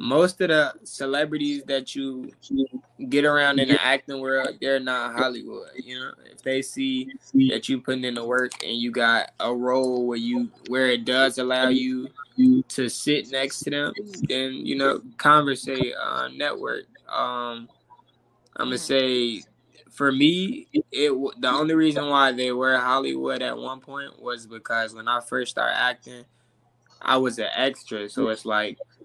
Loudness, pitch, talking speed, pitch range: -24 LUFS, 135 Hz, 165 wpm, 125-150 Hz